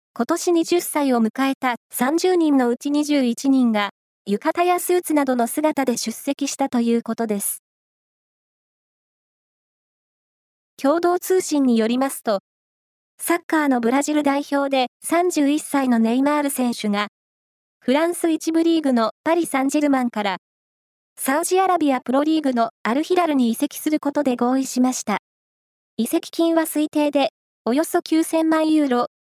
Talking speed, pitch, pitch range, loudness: 275 characters per minute, 280 Hz, 245-320 Hz, -20 LUFS